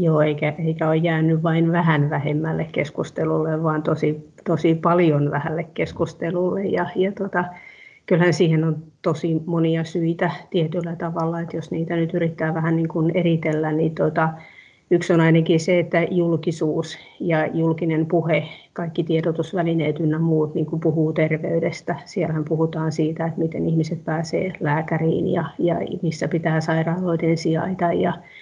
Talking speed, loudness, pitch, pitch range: 145 wpm, -21 LUFS, 165 Hz, 160-170 Hz